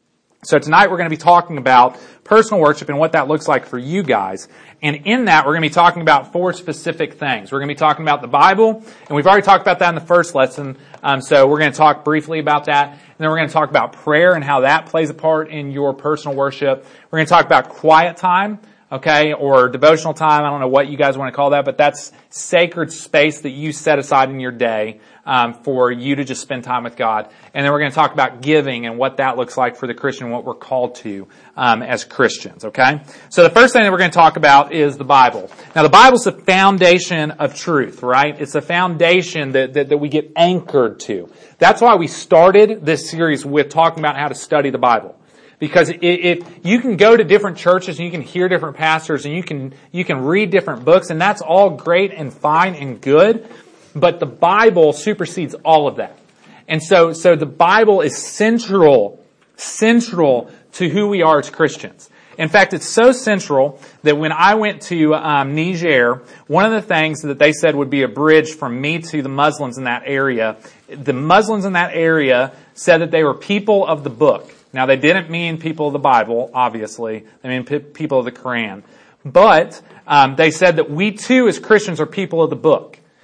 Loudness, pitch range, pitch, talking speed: -14 LUFS, 140-175 Hz, 155 Hz, 230 wpm